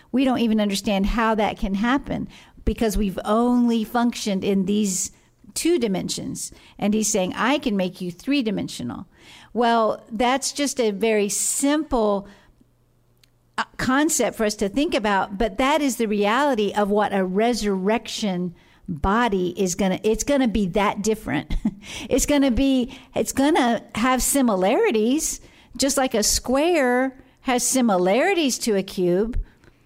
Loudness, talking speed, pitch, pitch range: -22 LUFS, 150 wpm, 225 Hz, 205-260 Hz